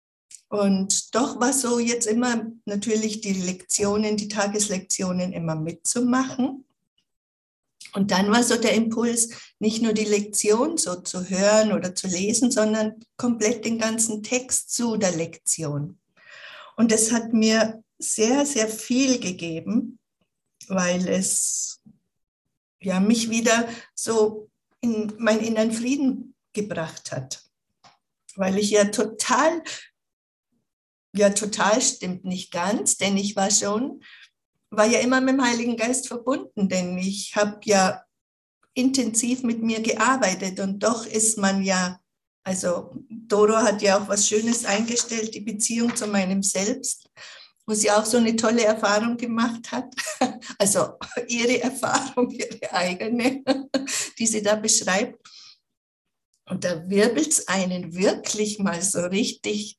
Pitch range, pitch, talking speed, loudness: 195-235 Hz, 215 Hz, 130 wpm, -23 LUFS